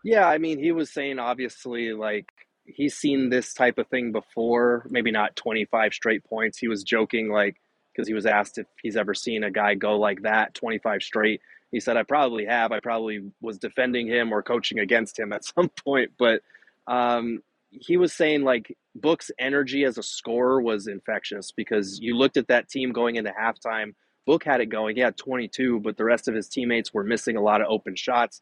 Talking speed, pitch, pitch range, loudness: 205 wpm, 120 Hz, 110-130 Hz, -25 LUFS